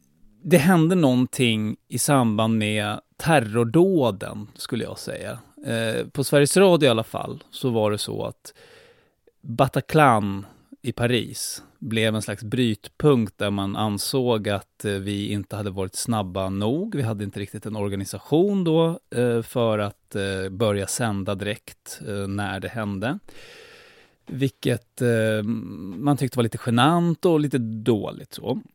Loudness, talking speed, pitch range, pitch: -23 LUFS, 140 wpm, 105-145 Hz, 115 Hz